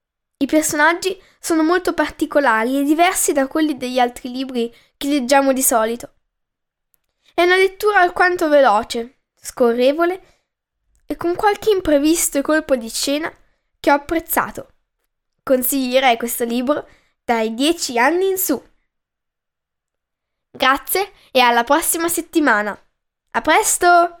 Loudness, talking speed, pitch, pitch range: -17 LUFS, 115 wpm, 295 Hz, 260-345 Hz